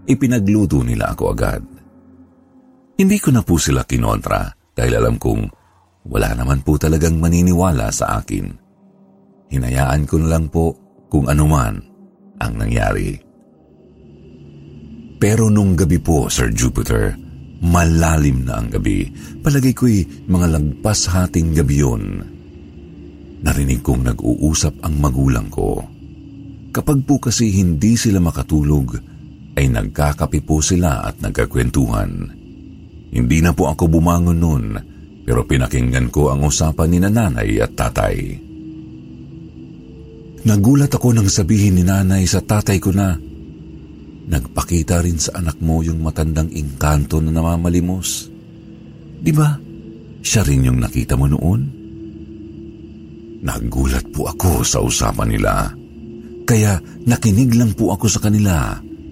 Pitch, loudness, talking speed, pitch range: 85 Hz, -17 LUFS, 120 wpm, 75-110 Hz